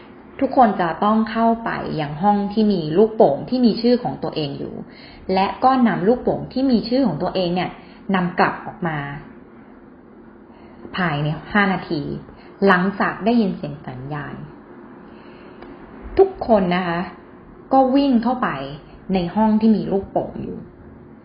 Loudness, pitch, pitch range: -19 LUFS, 200 Hz, 180-230 Hz